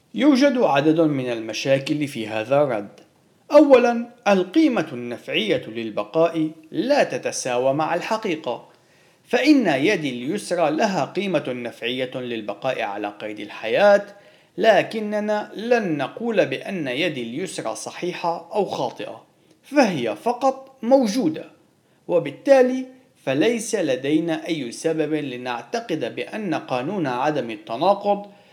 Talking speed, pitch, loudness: 100 wpm, 175 Hz, -21 LUFS